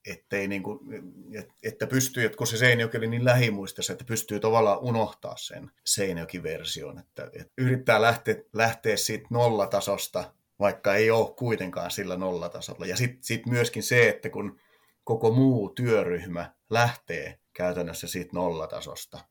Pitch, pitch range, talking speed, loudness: 115 Hz, 105-120 Hz, 140 wpm, -26 LUFS